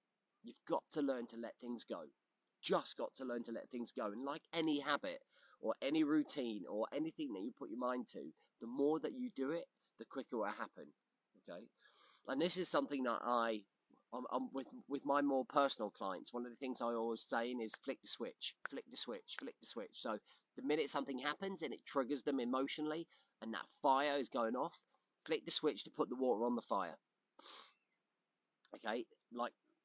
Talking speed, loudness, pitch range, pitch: 205 wpm, -42 LUFS, 120-170 Hz, 140 Hz